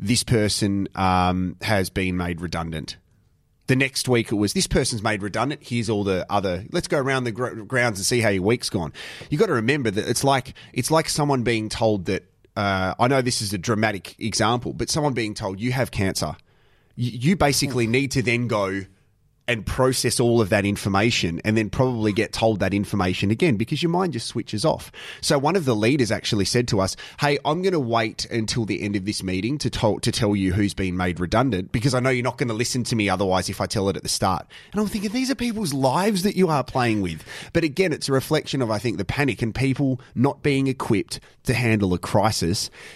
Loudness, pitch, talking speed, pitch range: -22 LUFS, 115 Hz, 230 wpm, 100-135 Hz